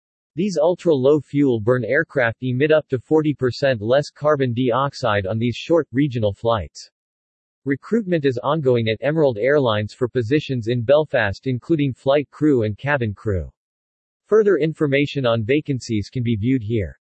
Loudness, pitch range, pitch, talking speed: -20 LUFS, 115-150 Hz, 130 Hz, 145 wpm